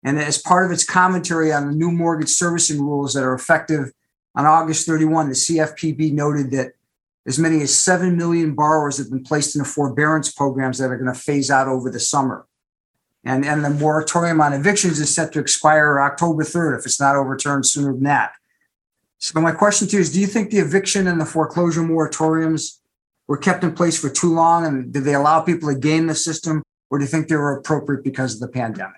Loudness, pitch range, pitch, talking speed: -18 LUFS, 140-165 Hz, 155 Hz, 215 wpm